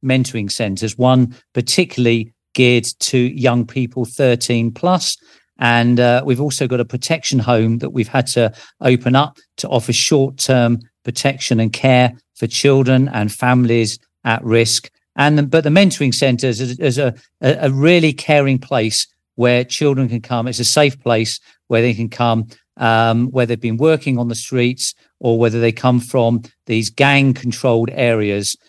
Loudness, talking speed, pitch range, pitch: -16 LUFS, 165 wpm, 115-135 Hz, 125 Hz